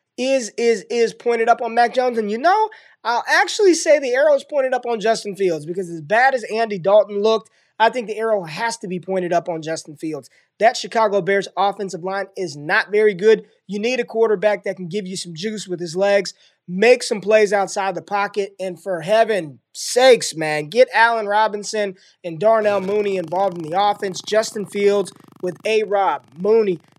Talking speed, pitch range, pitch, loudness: 200 wpm, 190-225 Hz, 210 Hz, -19 LUFS